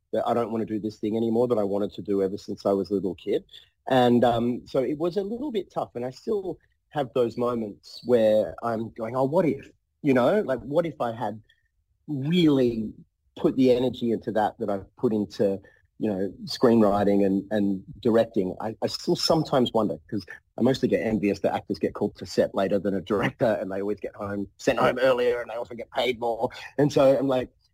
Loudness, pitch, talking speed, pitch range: -25 LUFS, 115 Hz, 225 wpm, 100-125 Hz